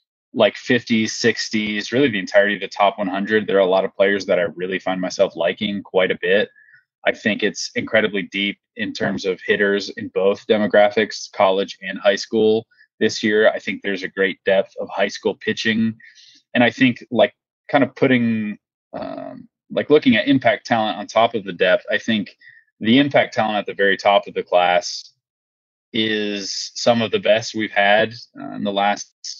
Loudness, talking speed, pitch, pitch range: -19 LUFS, 190 wpm, 110 Hz, 100-120 Hz